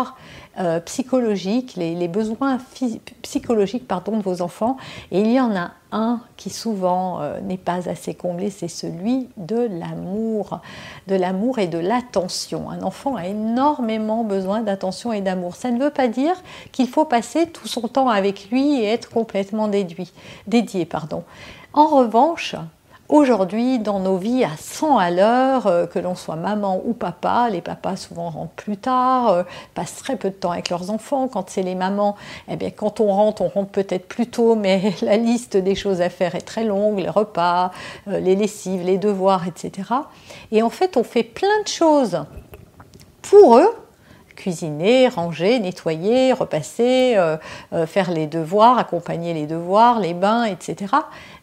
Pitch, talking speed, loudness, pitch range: 210 Hz, 165 wpm, -20 LUFS, 185-245 Hz